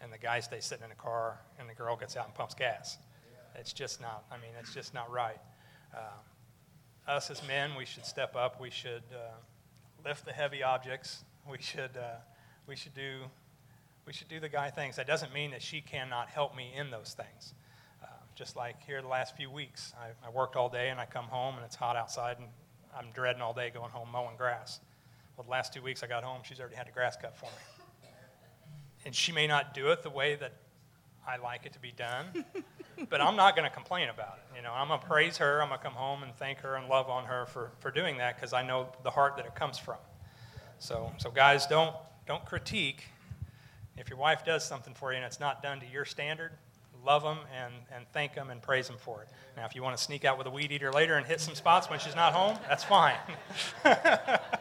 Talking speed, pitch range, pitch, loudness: 240 wpm, 120-145 Hz, 130 Hz, -33 LUFS